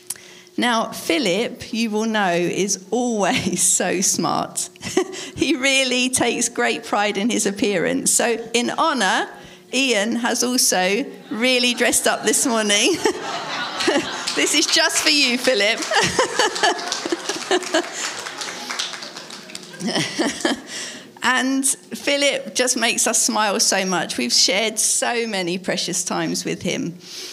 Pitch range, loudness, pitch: 215-300 Hz, -19 LUFS, 245 Hz